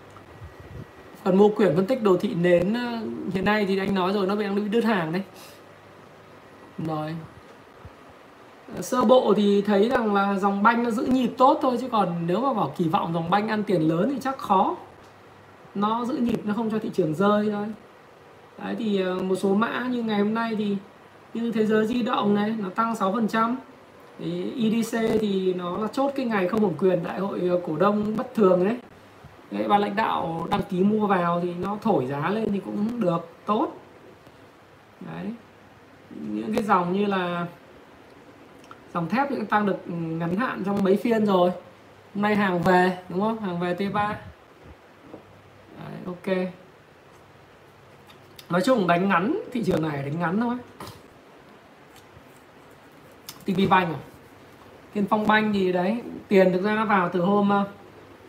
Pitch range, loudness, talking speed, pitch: 180-220 Hz, -24 LUFS, 170 wpm, 200 Hz